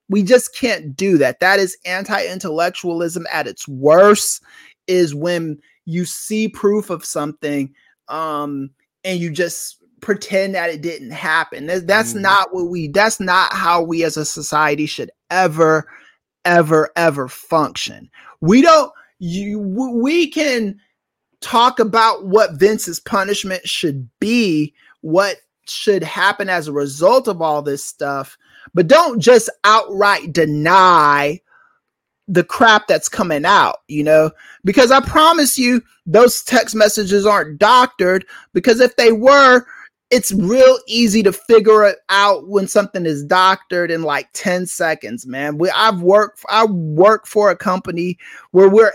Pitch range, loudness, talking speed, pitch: 165-220 Hz, -15 LUFS, 140 wpm, 190 Hz